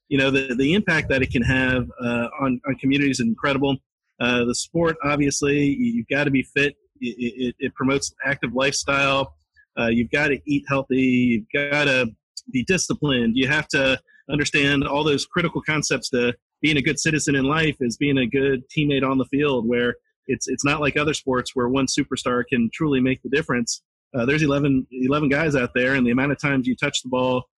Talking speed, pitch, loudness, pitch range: 205 wpm, 135 Hz, -21 LUFS, 125-145 Hz